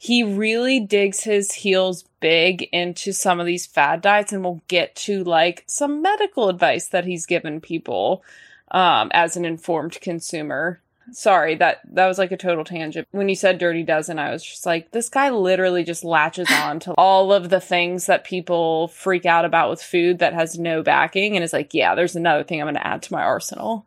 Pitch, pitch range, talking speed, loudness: 180 Hz, 170-195 Hz, 205 wpm, -20 LUFS